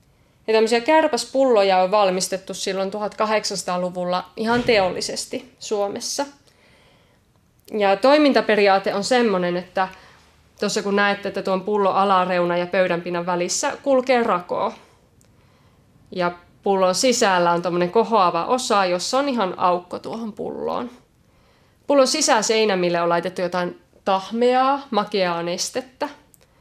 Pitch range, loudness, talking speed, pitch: 180-235 Hz, -20 LUFS, 100 wpm, 200 Hz